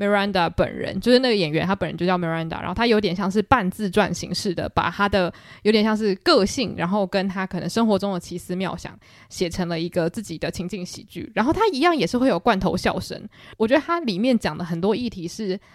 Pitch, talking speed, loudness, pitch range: 195 Hz, 385 characters per minute, -22 LUFS, 180-220 Hz